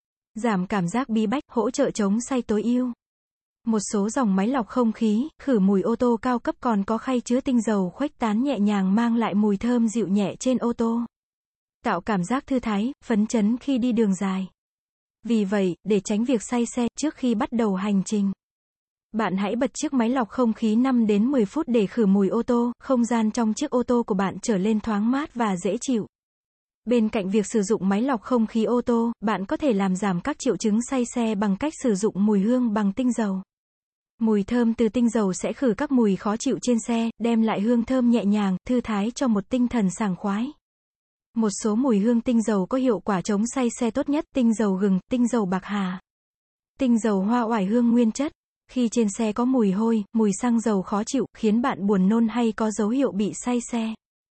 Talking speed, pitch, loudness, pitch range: 230 wpm, 230 Hz, -23 LUFS, 210-245 Hz